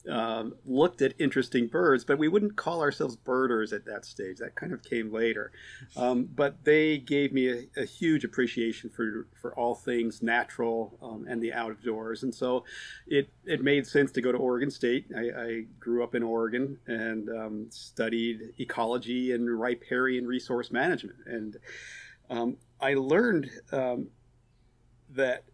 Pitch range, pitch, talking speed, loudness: 115-130 Hz, 120 Hz, 160 wpm, -29 LUFS